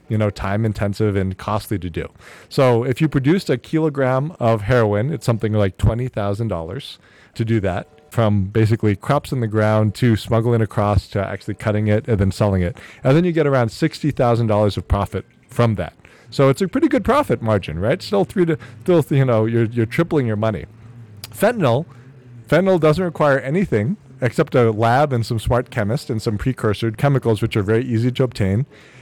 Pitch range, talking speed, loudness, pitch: 105-135 Hz, 195 wpm, -19 LUFS, 115 Hz